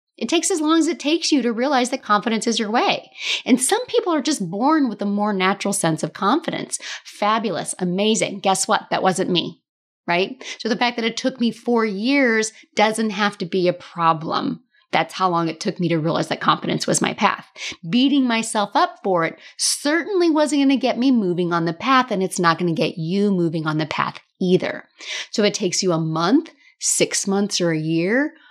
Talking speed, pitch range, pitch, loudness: 210 wpm, 180-260 Hz, 215 Hz, -20 LUFS